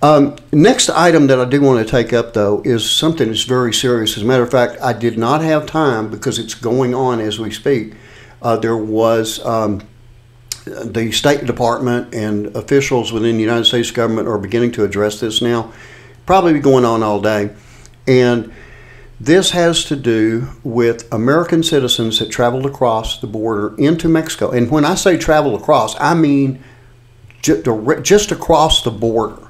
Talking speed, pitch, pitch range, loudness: 175 wpm, 120 Hz, 115-140 Hz, -14 LUFS